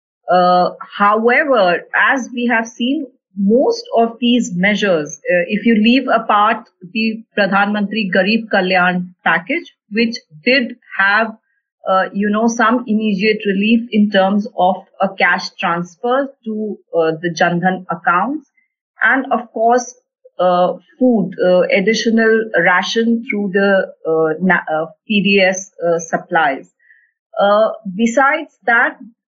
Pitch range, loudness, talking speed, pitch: 185-240 Hz, -15 LUFS, 120 wpm, 215 Hz